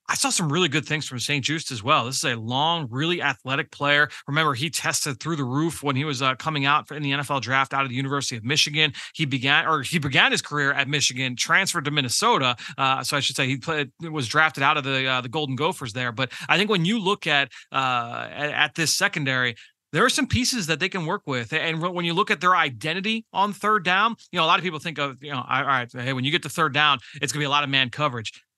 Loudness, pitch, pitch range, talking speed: -22 LUFS, 150 Hz, 135-165 Hz, 265 wpm